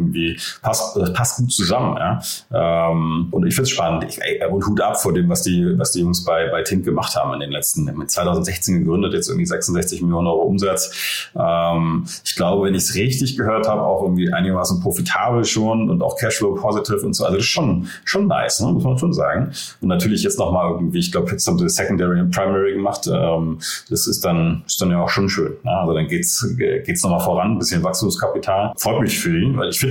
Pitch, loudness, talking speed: 100 Hz, -19 LUFS, 220 wpm